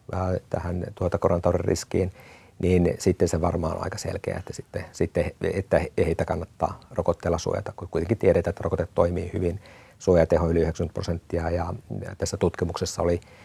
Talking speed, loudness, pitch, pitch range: 145 wpm, -26 LUFS, 90 Hz, 85-100 Hz